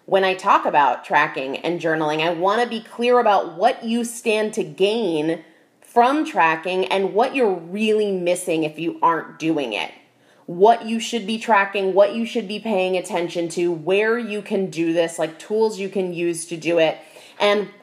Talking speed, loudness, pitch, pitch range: 190 wpm, -20 LUFS, 195 Hz, 170-220 Hz